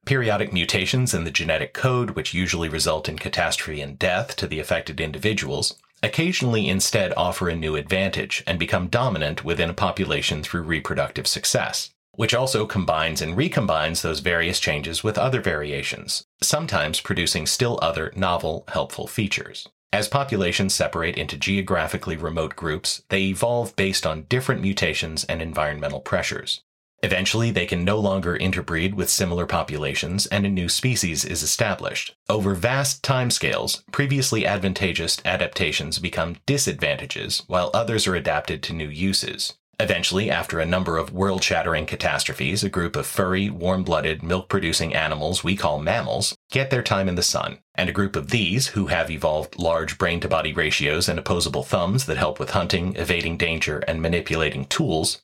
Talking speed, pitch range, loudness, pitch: 155 wpm, 80-100 Hz, -23 LUFS, 90 Hz